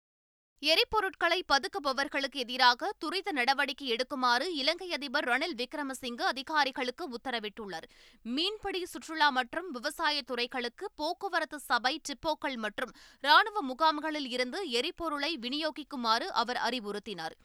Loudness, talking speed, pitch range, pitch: -31 LUFS, 95 wpm, 250-320 Hz, 285 Hz